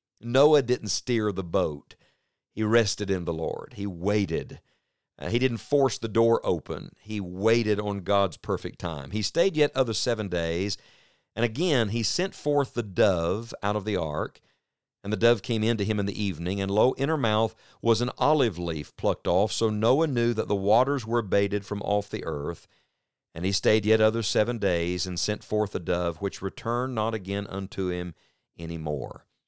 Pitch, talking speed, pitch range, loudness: 105 Hz, 190 wpm, 100-115 Hz, -26 LUFS